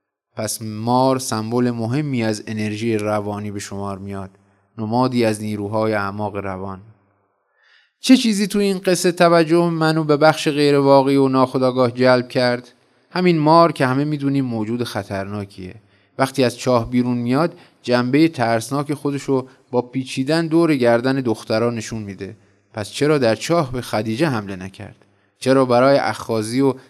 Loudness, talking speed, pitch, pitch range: -18 LUFS, 145 wpm, 125 Hz, 105-140 Hz